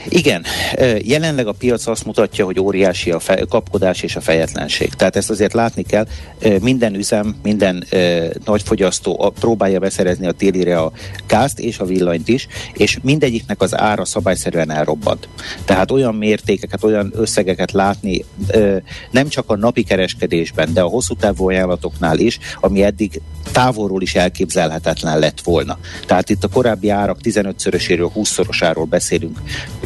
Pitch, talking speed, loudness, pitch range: 100 Hz, 145 wpm, -16 LUFS, 90-110 Hz